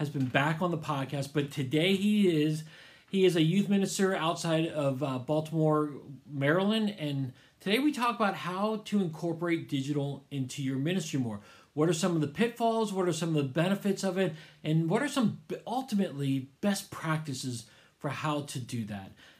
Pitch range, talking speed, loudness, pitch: 140-190 Hz, 185 wpm, -30 LUFS, 155 Hz